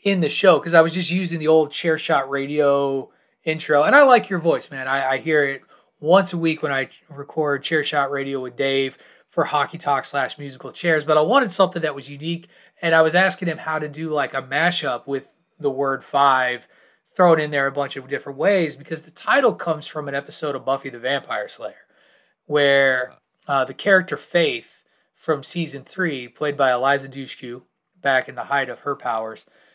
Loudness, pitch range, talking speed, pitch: -20 LUFS, 135-165 Hz, 205 wpm, 150 Hz